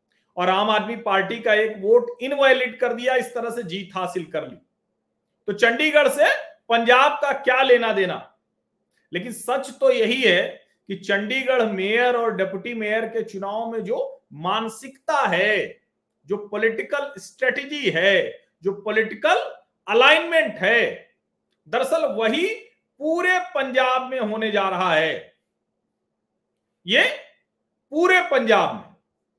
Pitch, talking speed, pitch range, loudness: 240 Hz, 130 wpm, 215-280 Hz, -20 LUFS